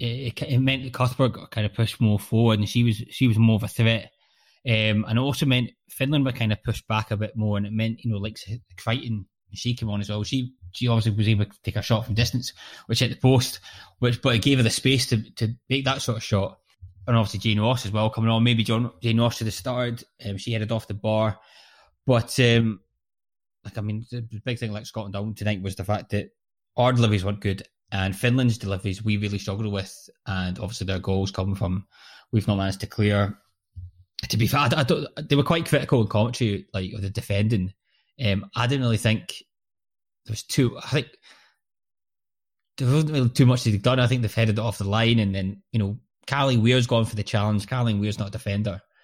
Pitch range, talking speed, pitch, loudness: 105-120 Hz, 235 wpm, 110 Hz, -24 LUFS